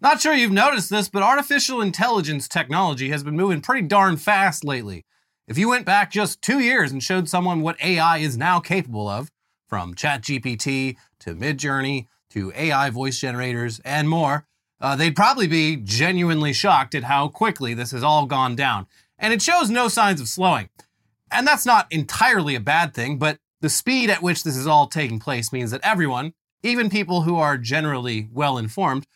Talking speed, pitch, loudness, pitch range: 185 wpm, 155 Hz, -20 LUFS, 135-190 Hz